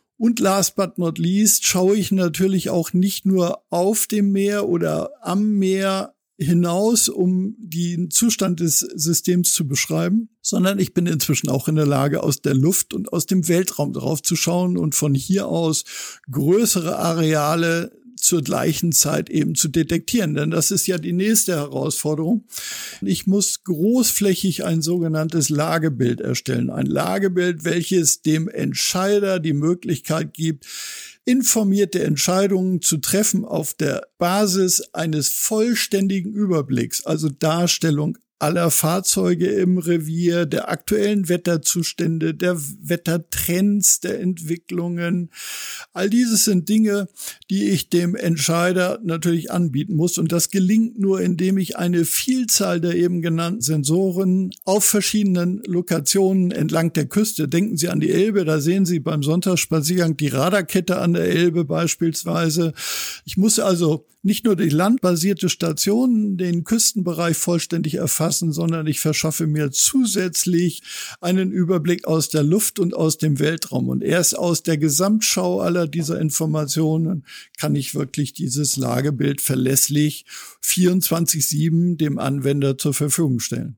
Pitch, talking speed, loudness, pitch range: 175 Hz, 135 wpm, -19 LUFS, 160-195 Hz